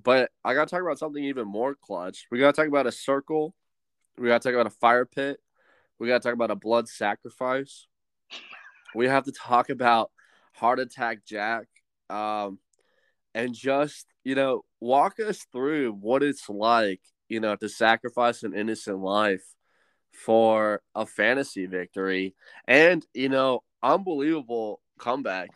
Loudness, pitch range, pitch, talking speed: -25 LUFS, 110-135 Hz, 120 Hz, 160 wpm